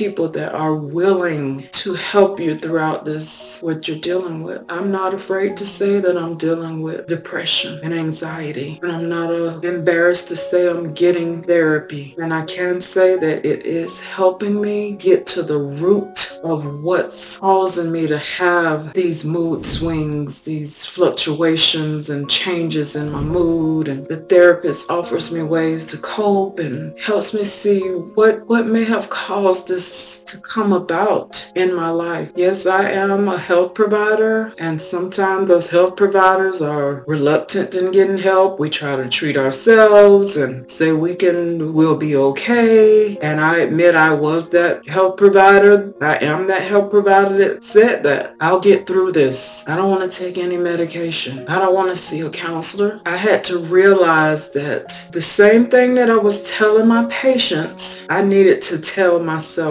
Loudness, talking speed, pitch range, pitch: -16 LUFS, 170 wpm, 160-195 Hz, 175 Hz